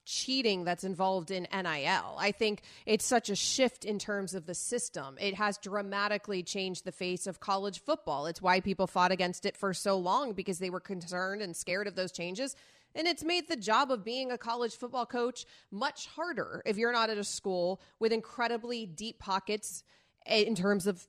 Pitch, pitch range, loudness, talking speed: 205 Hz, 190-235 Hz, -33 LUFS, 195 wpm